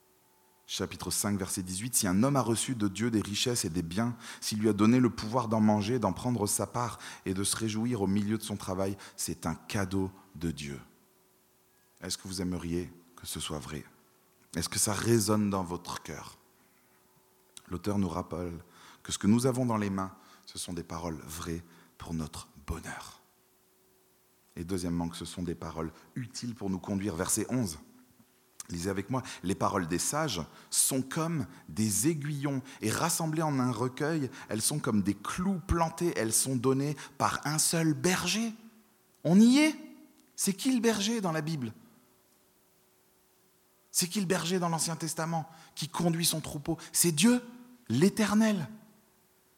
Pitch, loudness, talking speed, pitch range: 110 Hz, -30 LUFS, 170 wpm, 95-160 Hz